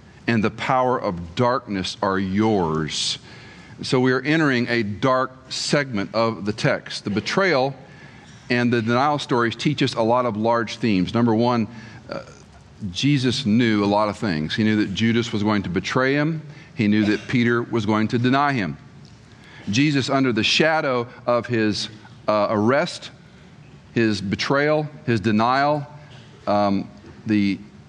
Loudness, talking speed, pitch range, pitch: -21 LUFS, 155 wpm, 105-130 Hz, 115 Hz